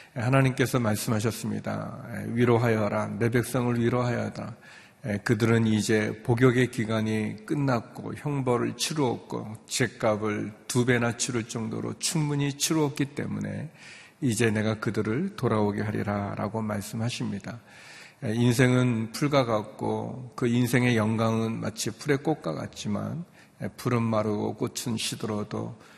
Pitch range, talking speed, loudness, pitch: 110-125 Hz, 285 characters per minute, -27 LUFS, 115 Hz